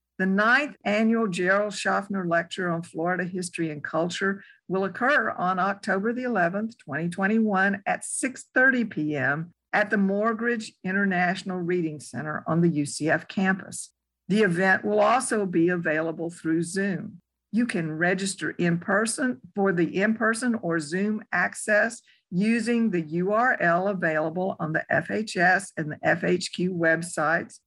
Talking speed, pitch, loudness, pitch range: 130 wpm, 190 Hz, -25 LUFS, 170-215 Hz